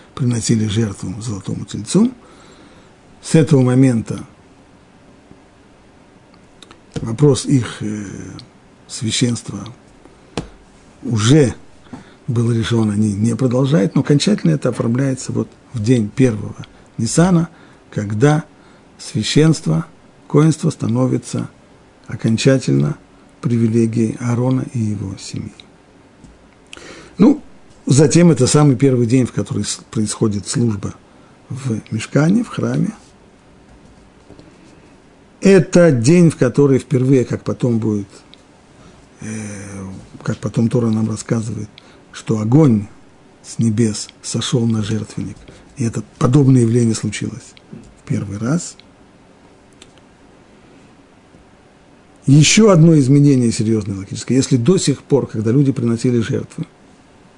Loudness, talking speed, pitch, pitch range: -16 LUFS, 95 wpm, 120 Hz, 110-140 Hz